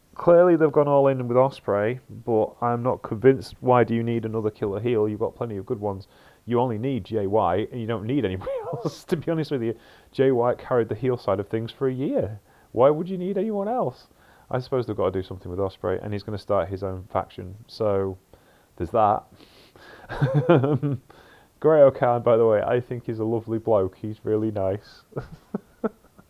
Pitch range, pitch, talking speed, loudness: 105-135 Hz, 120 Hz, 210 wpm, -24 LUFS